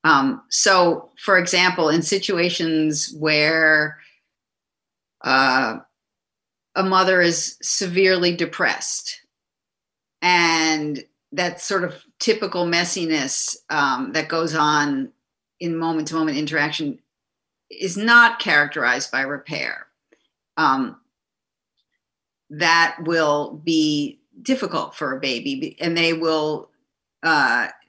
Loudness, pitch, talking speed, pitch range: -19 LUFS, 170 Hz, 95 wpm, 155-190 Hz